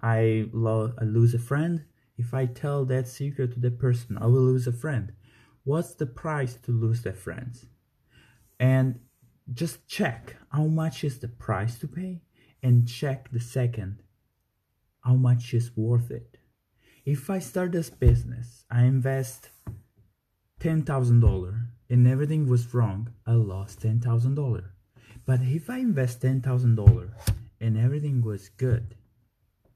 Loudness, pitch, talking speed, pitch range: -26 LUFS, 120 Hz, 140 wpm, 115-130 Hz